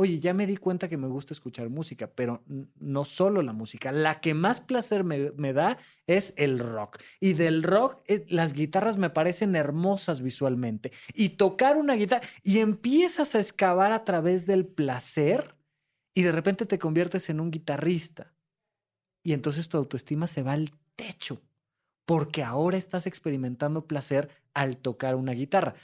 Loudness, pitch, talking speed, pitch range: -27 LUFS, 165 Hz, 165 wpm, 140-190 Hz